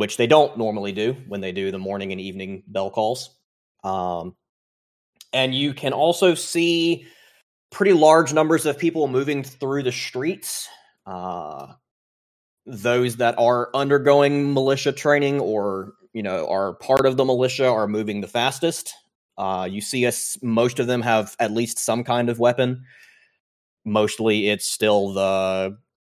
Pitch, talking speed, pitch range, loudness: 120 Hz, 155 wpm, 100-135 Hz, -21 LUFS